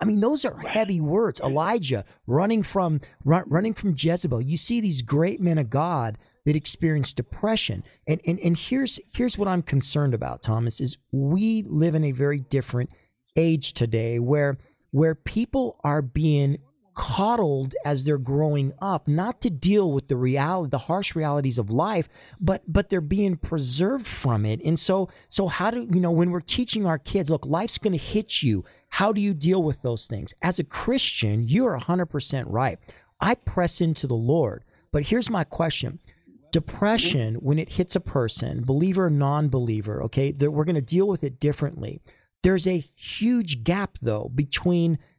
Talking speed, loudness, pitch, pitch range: 175 wpm, -24 LUFS, 160 Hz, 135-185 Hz